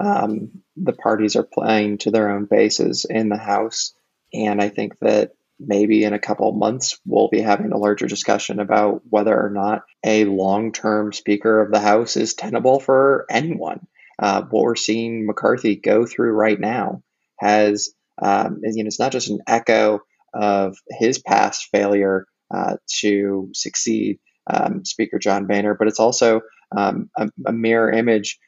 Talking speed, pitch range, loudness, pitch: 170 wpm, 105-110 Hz, -19 LUFS, 105 Hz